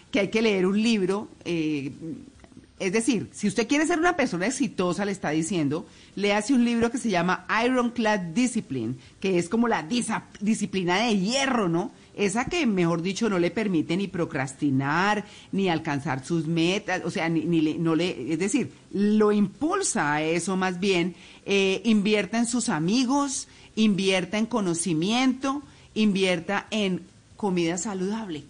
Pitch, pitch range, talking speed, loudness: 195 Hz, 170-225 Hz, 160 wpm, -25 LUFS